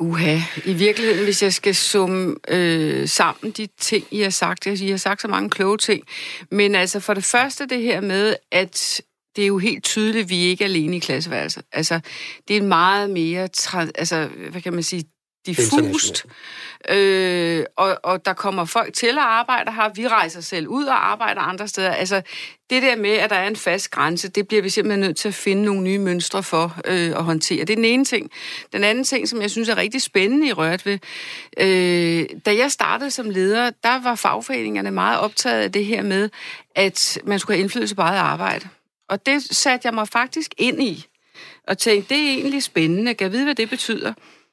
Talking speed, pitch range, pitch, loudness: 210 wpm, 180-225 Hz, 200 Hz, -19 LUFS